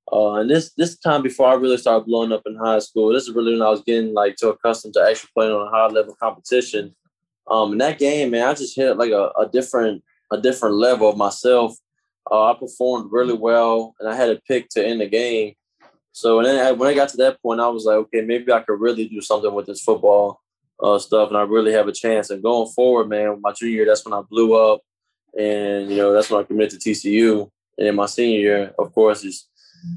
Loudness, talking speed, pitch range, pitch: -18 LUFS, 245 wpm, 105-120 Hz, 110 Hz